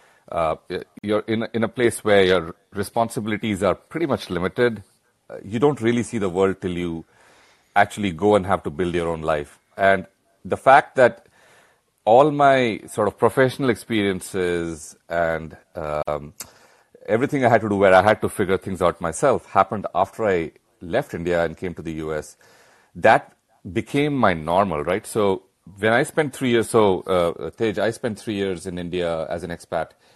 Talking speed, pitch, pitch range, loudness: 175 wpm, 100 Hz, 85-115 Hz, -21 LUFS